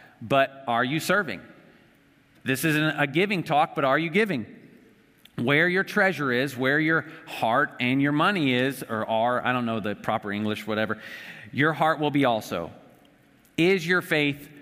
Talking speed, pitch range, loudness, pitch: 170 wpm, 125-160 Hz, -24 LUFS, 145 Hz